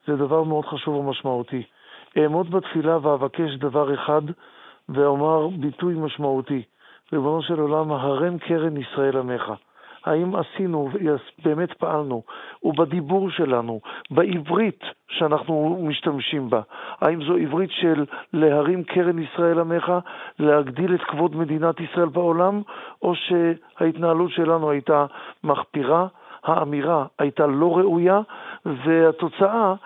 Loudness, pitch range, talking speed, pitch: -22 LUFS, 145-170 Hz, 110 wpm, 160 Hz